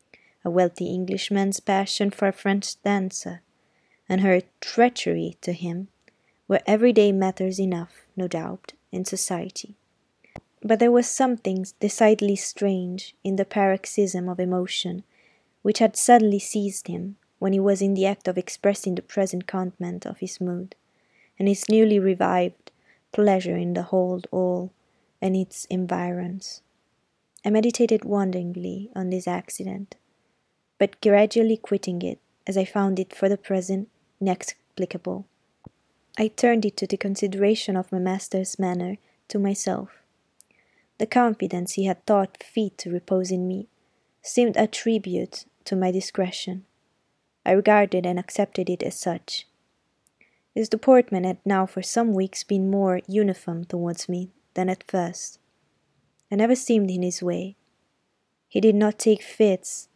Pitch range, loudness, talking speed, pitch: 185-210 Hz, -24 LUFS, 140 wpm, 195 Hz